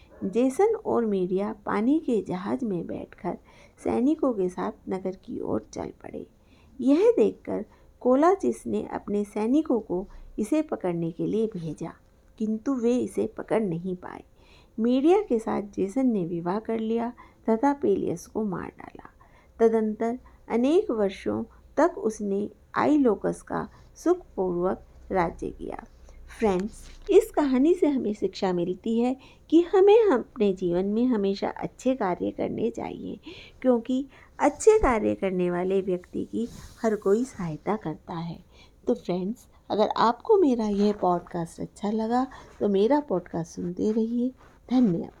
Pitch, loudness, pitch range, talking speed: 220 Hz, -26 LUFS, 185-260 Hz, 135 wpm